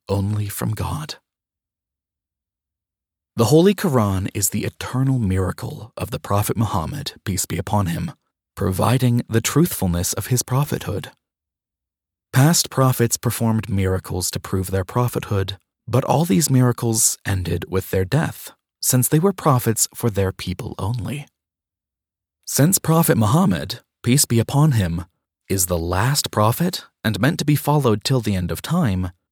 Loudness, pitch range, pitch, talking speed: -20 LUFS, 90-125 Hz, 105 Hz, 140 wpm